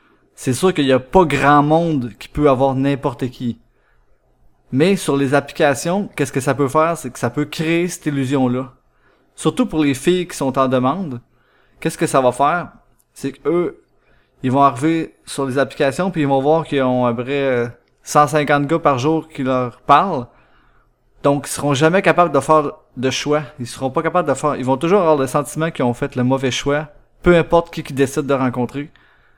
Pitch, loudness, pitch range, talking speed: 140 Hz, -17 LUFS, 130-155 Hz, 205 wpm